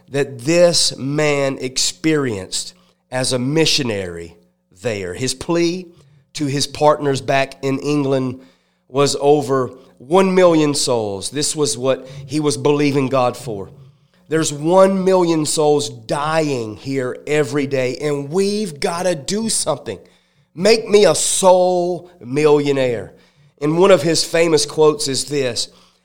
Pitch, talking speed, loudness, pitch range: 145 Hz, 130 wpm, -17 LUFS, 135-165 Hz